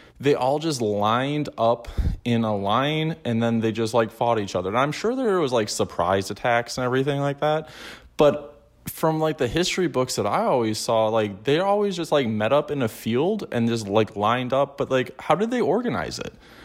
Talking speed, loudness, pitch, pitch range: 215 wpm, -23 LUFS, 125 Hz, 110-150 Hz